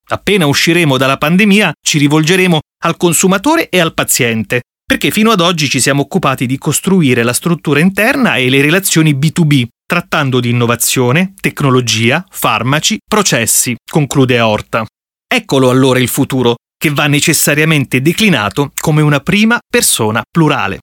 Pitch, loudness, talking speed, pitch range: 150 Hz, -11 LUFS, 140 wpm, 130-175 Hz